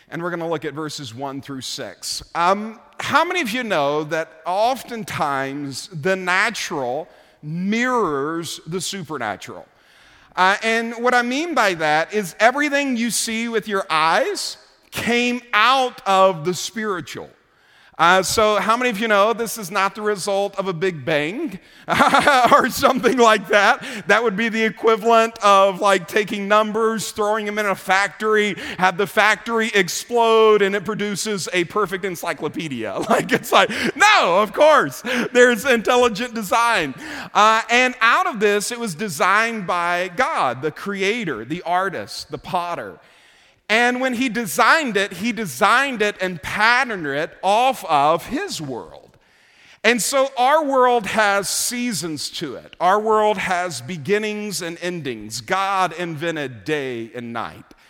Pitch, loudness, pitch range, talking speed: 205 Hz, -19 LUFS, 180-230 Hz, 150 wpm